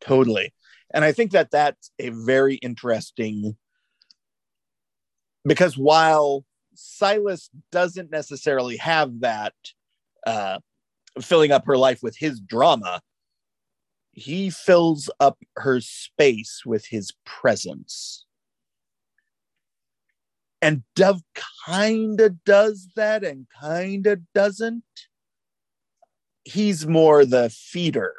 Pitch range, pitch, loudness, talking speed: 130-195 Hz, 155 Hz, -21 LUFS, 100 wpm